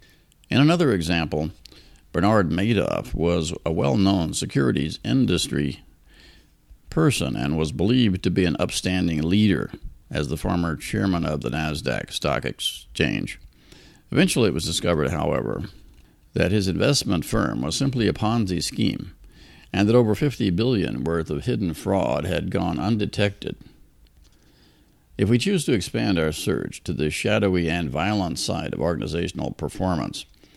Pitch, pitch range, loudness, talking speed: 85 Hz, 75-100 Hz, -23 LUFS, 140 wpm